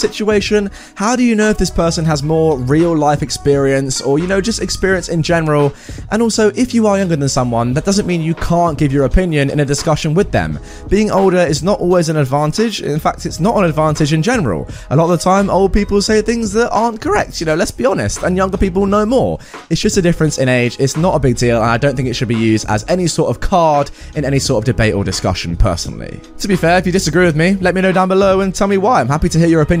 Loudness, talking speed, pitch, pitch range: -14 LUFS, 270 wpm, 170 Hz, 140-195 Hz